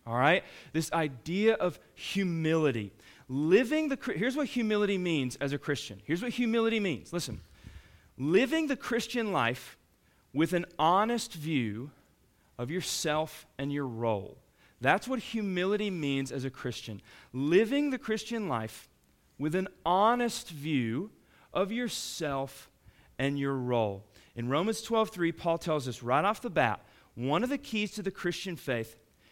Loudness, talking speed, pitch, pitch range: -31 LUFS, 145 wpm, 160 Hz, 125-210 Hz